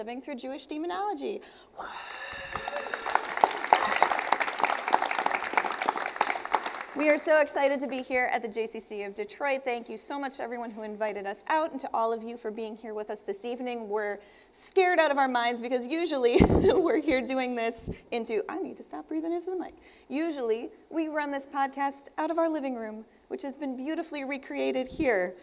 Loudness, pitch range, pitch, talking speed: -29 LUFS, 230-325 Hz, 275 Hz, 175 wpm